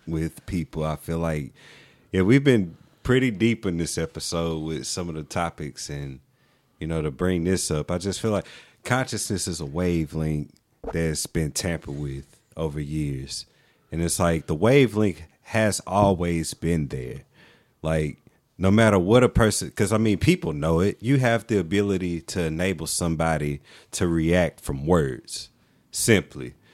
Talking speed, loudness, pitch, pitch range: 160 wpm, -24 LUFS, 85 Hz, 80-105 Hz